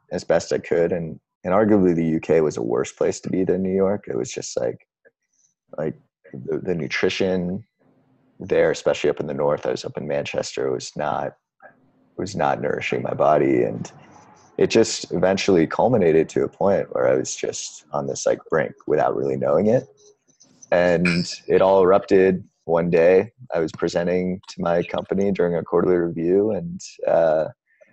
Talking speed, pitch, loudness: 180 wpm, 100 Hz, -21 LUFS